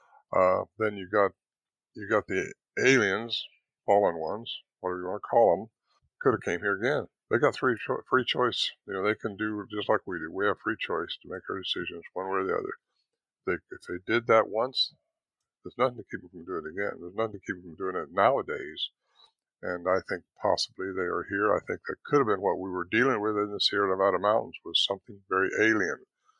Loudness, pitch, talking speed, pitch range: -28 LUFS, 100 Hz, 225 wpm, 95-110 Hz